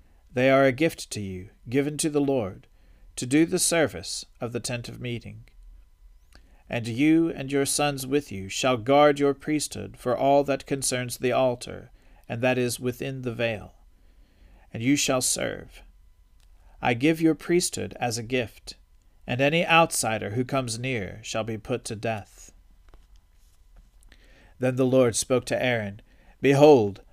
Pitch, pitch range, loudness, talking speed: 120 Hz, 95-135 Hz, -25 LUFS, 155 wpm